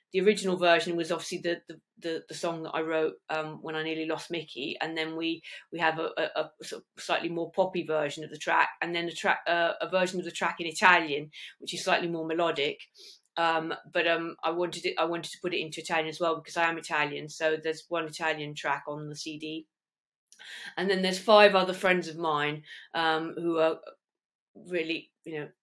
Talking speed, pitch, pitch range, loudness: 220 wpm, 165 Hz, 160-175 Hz, -29 LUFS